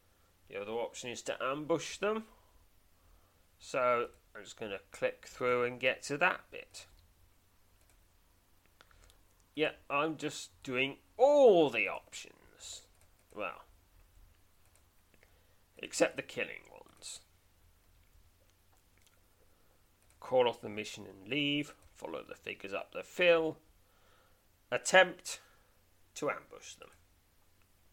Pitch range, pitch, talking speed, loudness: 90-145 Hz, 90 Hz, 100 wpm, -33 LUFS